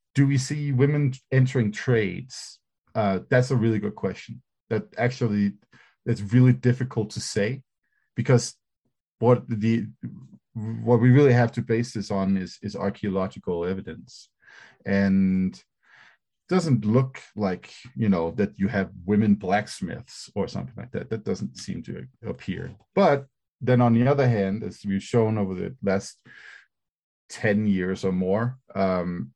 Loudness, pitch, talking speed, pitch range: -24 LUFS, 110 Hz, 145 wpm, 100-125 Hz